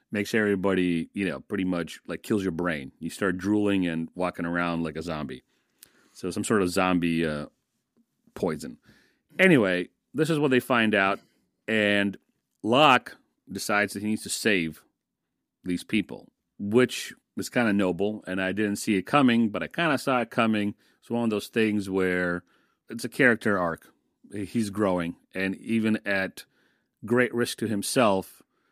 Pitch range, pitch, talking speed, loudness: 90-110 Hz, 100 Hz, 165 wpm, -26 LUFS